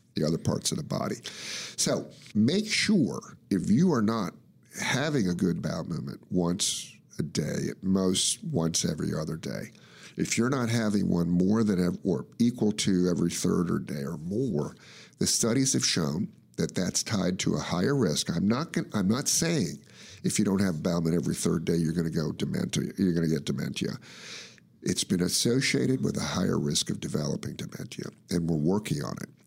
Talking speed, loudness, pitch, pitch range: 195 wpm, -28 LUFS, 90 Hz, 85-105 Hz